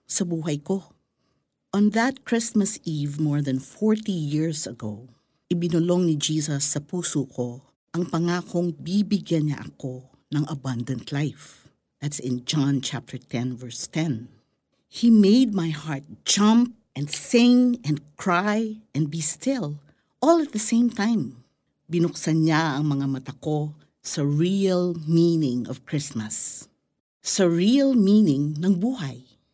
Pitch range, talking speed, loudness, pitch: 140-195 Hz, 135 wpm, -23 LUFS, 160 Hz